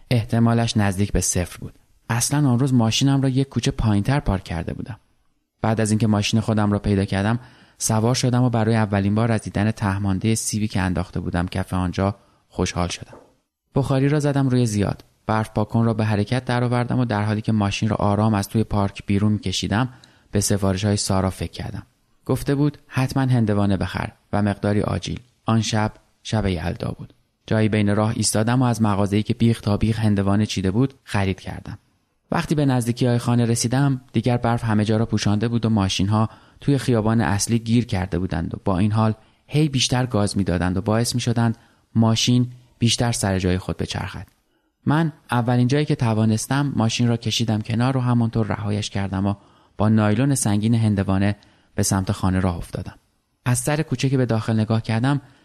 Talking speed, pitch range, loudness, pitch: 180 wpm, 100-120 Hz, -21 LUFS, 110 Hz